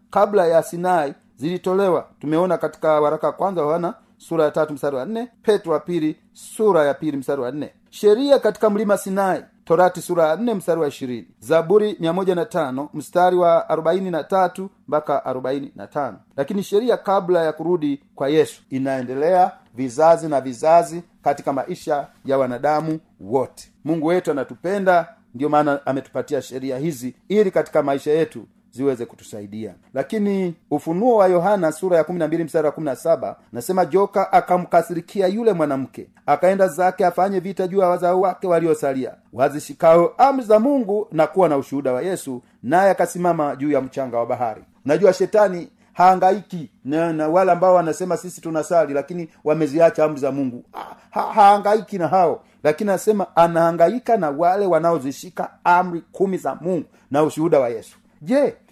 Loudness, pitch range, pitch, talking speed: -19 LUFS, 150-190 Hz, 170 Hz, 135 wpm